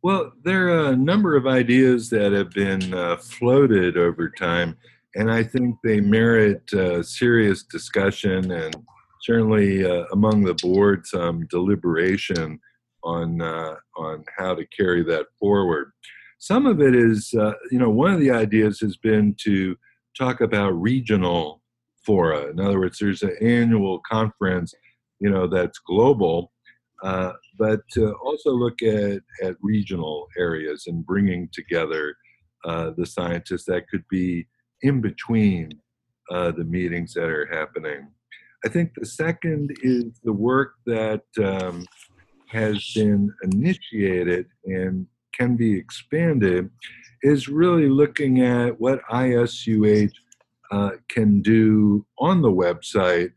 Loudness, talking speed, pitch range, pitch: -21 LUFS, 135 wpm, 90-120 Hz, 105 Hz